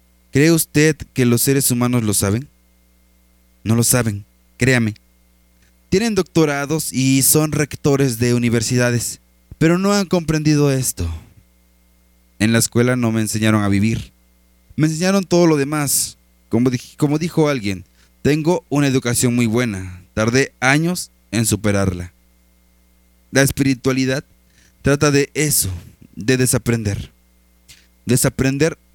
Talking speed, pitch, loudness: 120 wpm, 120 Hz, -17 LUFS